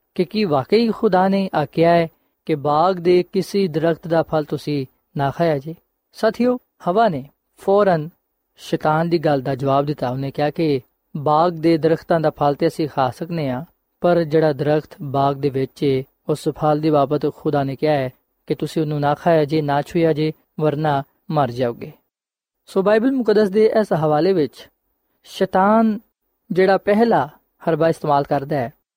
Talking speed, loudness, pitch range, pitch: 165 wpm, -19 LUFS, 145-185 Hz, 160 Hz